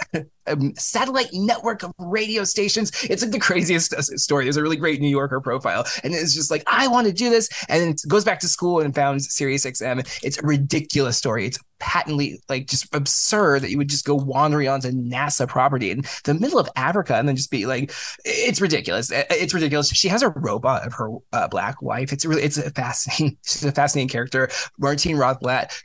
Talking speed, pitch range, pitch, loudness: 210 wpm, 135-175 Hz, 145 Hz, -21 LUFS